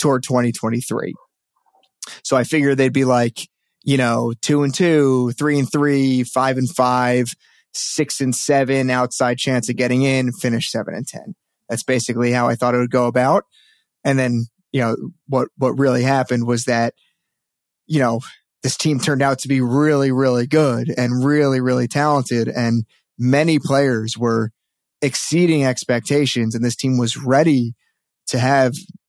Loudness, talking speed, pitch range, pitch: -18 LUFS, 160 wpm, 125-145 Hz, 130 Hz